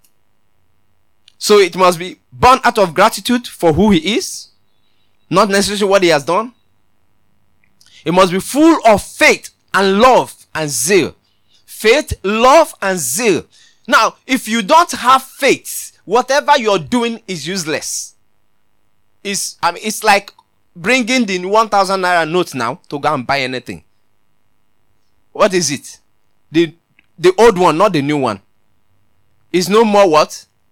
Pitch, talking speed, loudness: 175 Hz, 145 wpm, -13 LUFS